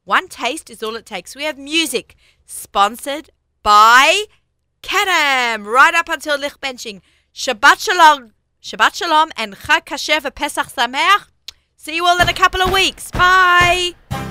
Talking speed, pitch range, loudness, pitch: 140 wpm, 250-350 Hz, -14 LUFS, 305 Hz